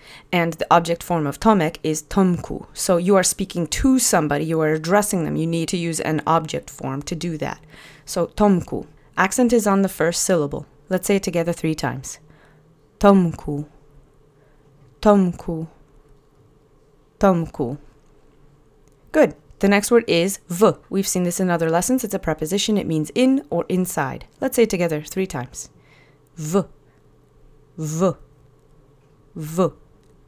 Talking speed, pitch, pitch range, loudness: 150 wpm, 165 Hz, 145-190 Hz, -20 LUFS